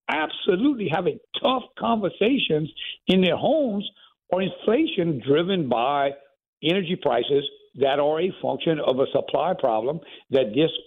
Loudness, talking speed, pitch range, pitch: -23 LUFS, 125 wpm, 145-205 Hz, 175 Hz